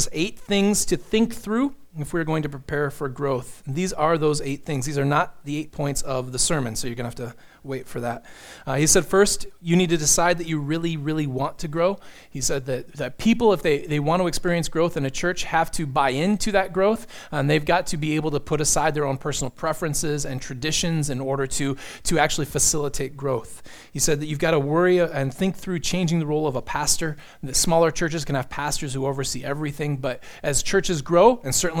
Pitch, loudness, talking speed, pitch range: 155 Hz, -23 LUFS, 235 wpm, 140-175 Hz